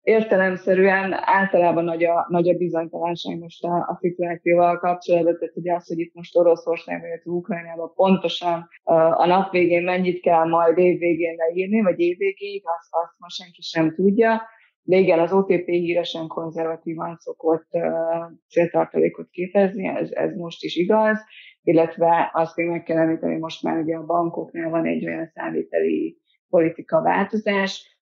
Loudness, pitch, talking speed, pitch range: -21 LUFS, 170 Hz, 145 wpm, 165-190 Hz